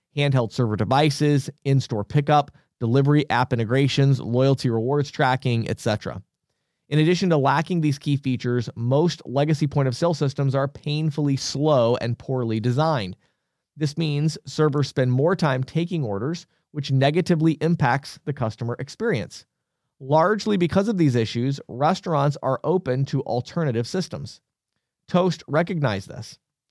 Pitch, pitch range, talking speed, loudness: 140 Hz, 130-155 Hz, 135 wpm, -22 LUFS